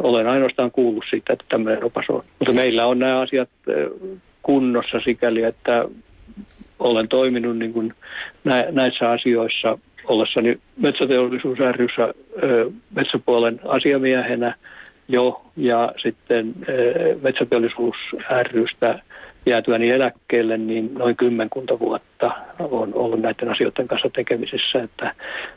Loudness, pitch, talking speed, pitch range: -20 LUFS, 125 Hz, 100 wpm, 115-130 Hz